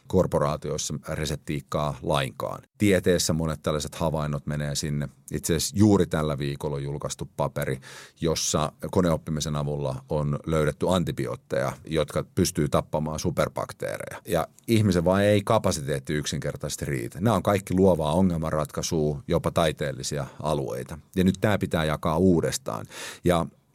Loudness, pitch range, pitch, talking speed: -26 LUFS, 75-95 Hz, 80 Hz, 125 wpm